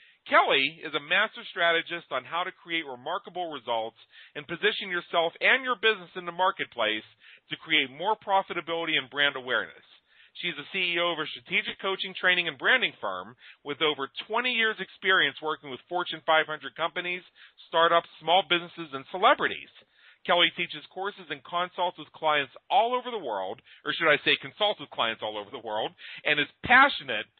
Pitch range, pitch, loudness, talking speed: 150-190 Hz, 170 Hz, -26 LUFS, 170 wpm